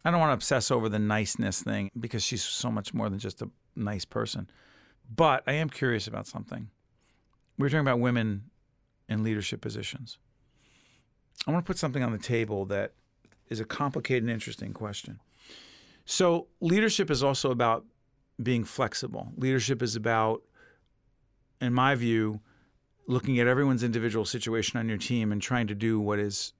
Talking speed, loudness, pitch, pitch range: 170 wpm, -29 LUFS, 120 Hz, 110-130 Hz